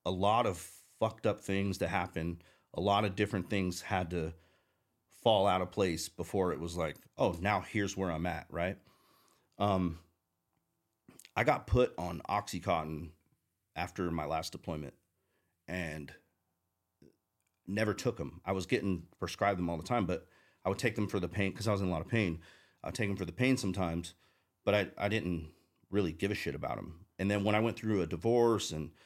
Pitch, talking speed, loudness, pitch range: 95 Hz, 195 wpm, -34 LUFS, 85-100 Hz